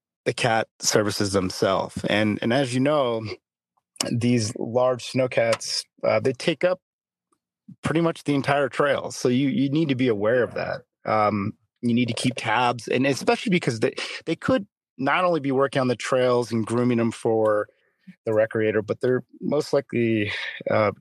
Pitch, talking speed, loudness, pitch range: 125 Hz, 175 wpm, -23 LUFS, 110-140 Hz